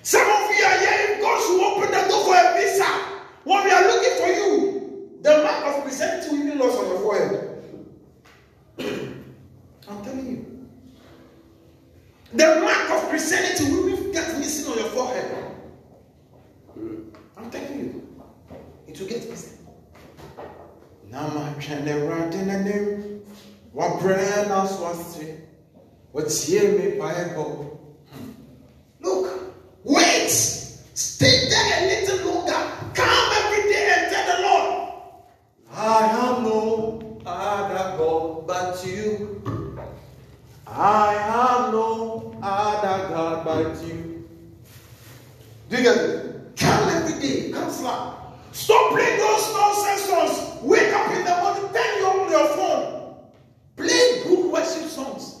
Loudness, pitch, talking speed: -21 LUFS, 270 Hz, 120 wpm